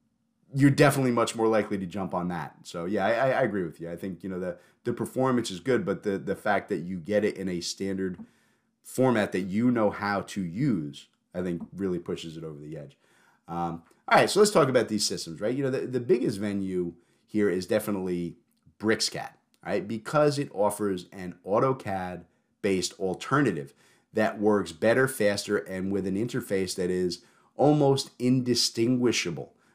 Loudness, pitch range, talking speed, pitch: -27 LUFS, 90-120 Hz, 180 wpm, 100 Hz